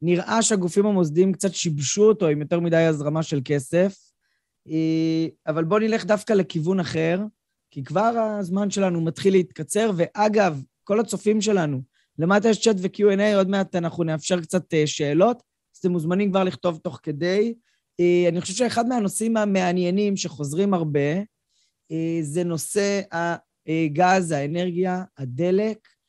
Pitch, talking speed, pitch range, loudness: 180 Hz, 130 wpm, 160-205 Hz, -22 LUFS